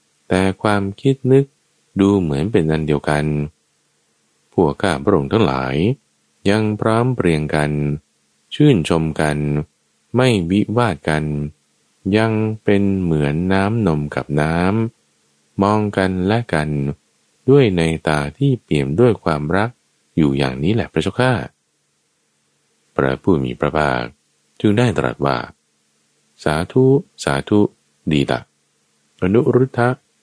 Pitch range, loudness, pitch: 75-110 Hz, -18 LUFS, 85 Hz